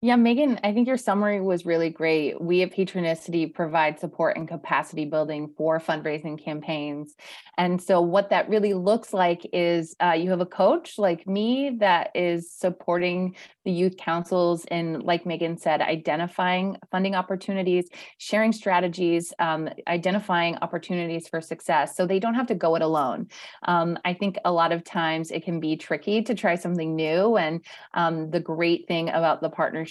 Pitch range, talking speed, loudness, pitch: 165-190 Hz, 175 wpm, -25 LUFS, 175 Hz